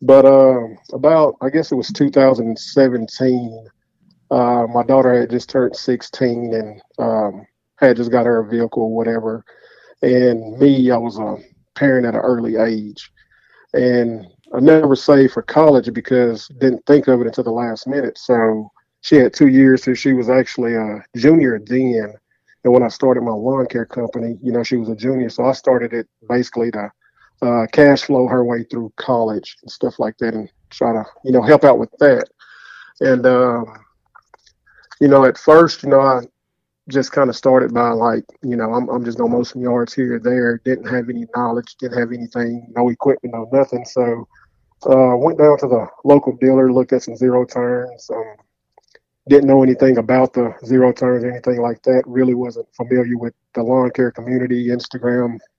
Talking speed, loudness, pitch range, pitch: 185 wpm, -15 LUFS, 115-130 Hz, 125 Hz